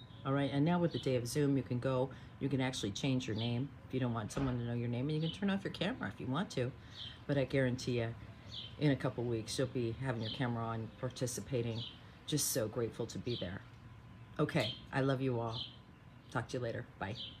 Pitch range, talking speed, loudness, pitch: 115-135 Hz, 240 wpm, -37 LUFS, 125 Hz